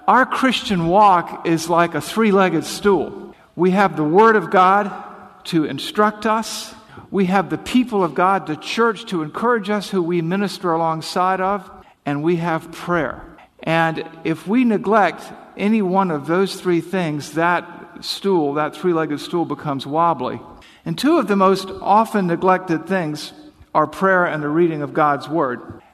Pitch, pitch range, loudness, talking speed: 185 Hz, 165-200 Hz, -18 LUFS, 160 wpm